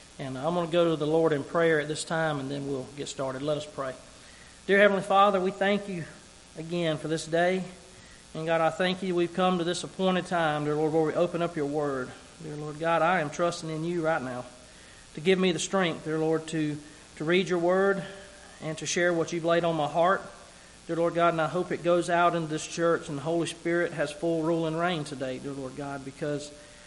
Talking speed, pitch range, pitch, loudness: 240 wpm, 150-175 Hz, 165 Hz, -28 LUFS